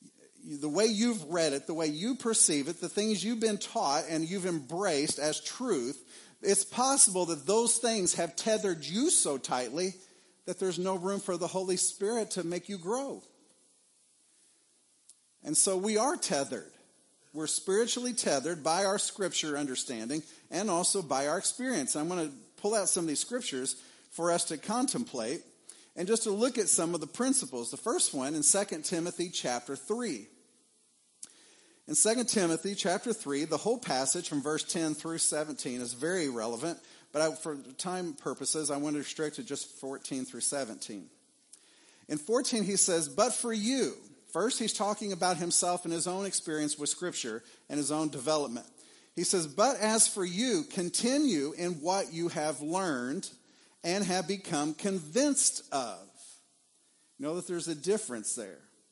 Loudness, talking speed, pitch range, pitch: -30 LUFS, 170 wpm, 155-220 Hz, 180 Hz